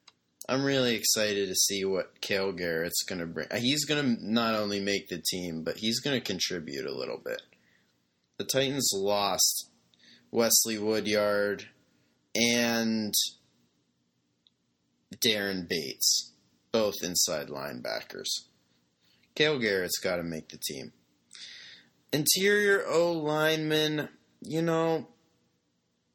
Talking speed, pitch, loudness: 105 wpm, 100 Hz, -28 LUFS